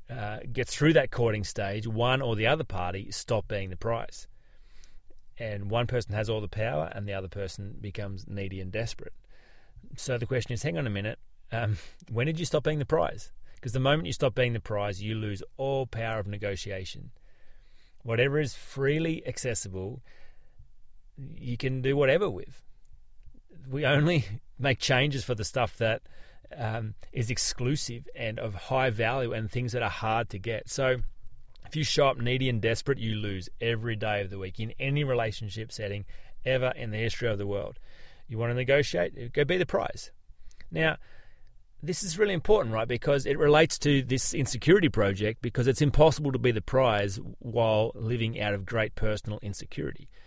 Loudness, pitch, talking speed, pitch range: -29 LUFS, 115 Hz, 180 wpm, 105-130 Hz